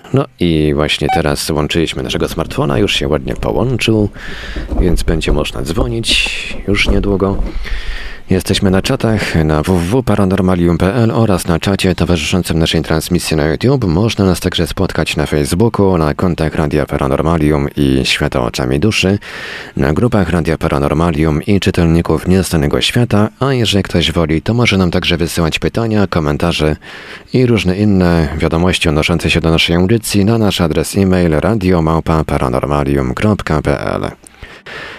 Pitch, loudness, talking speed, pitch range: 85 Hz, -13 LUFS, 130 wpm, 80-100 Hz